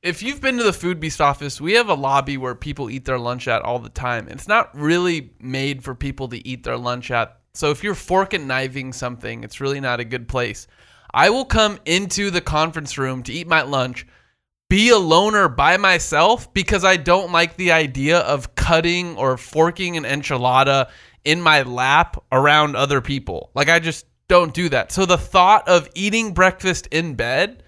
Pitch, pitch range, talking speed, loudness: 150 Hz, 130-175 Hz, 200 wpm, -18 LUFS